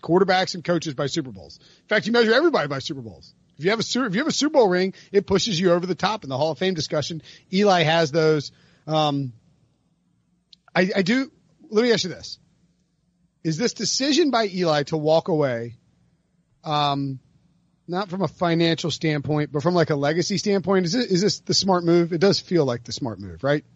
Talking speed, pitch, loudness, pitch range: 215 wpm, 170 Hz, -22 LUFS, 155-190 Hz